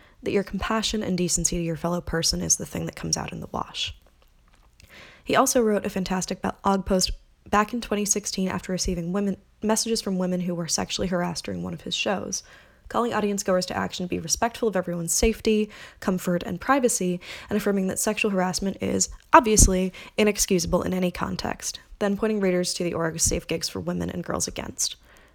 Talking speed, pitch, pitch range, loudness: 190 wpm, 185 Hz, 175-210 Hz, -25 LUFS